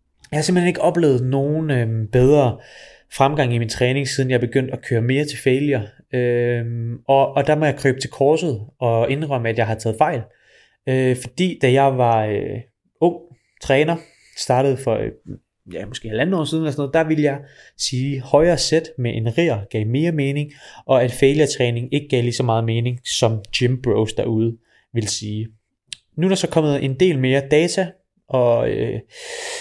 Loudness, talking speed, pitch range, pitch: -19 LUFS, 195 wpm, 120-150 Hz, 135 Hz